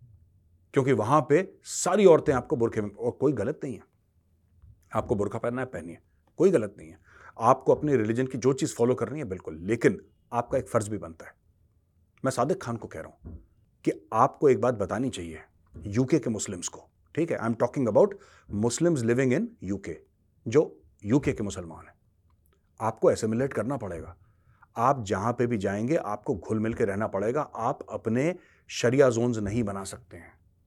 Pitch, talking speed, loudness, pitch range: 110 Hz, 180 wpm, -27 LUFS, 90-125 Hz